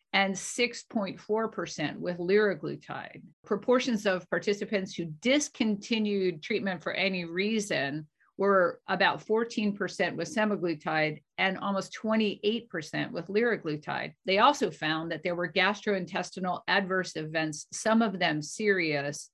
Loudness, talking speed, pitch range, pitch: -29 LUFS, 110 wpm, 170-215 Hz, 190 Hz